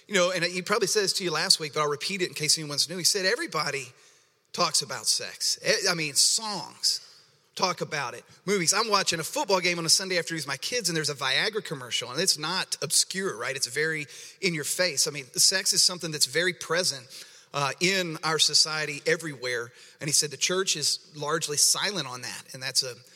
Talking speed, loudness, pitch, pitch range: 220 wpm, -25 LUFS, 165 Hz, 150-190 Hz